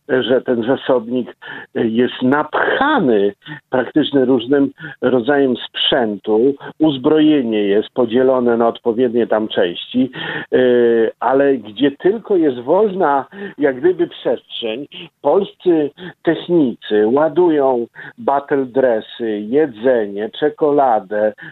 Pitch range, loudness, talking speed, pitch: 120-155 Hz, -16 LUFS, 85 wpm, 135 Hz